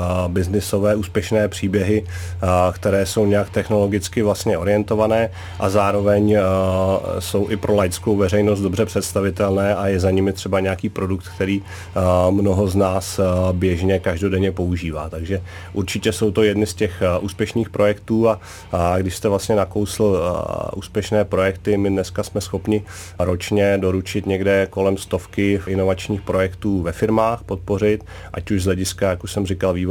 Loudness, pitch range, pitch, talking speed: -20 LUFS, 95-105 Hz, 100 Hz, 140 wpm